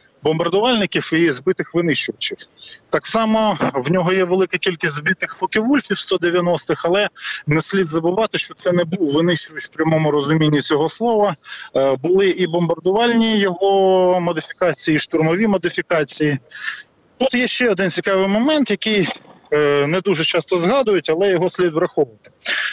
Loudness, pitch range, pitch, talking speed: -17 LUFS, 160-195 Hz, 180 Hz, 135 wpm